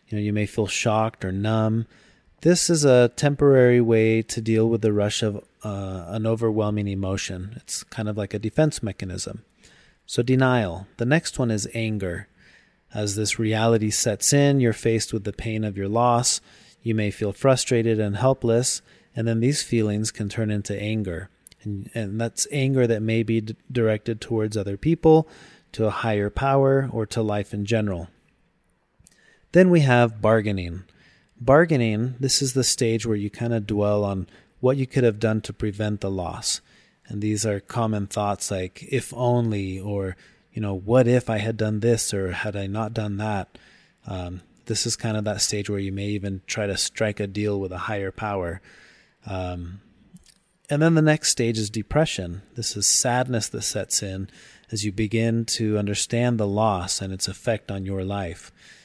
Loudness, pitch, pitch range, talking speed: -23 LUFS, 110 Hz, 100-120 Hz, 185 wpm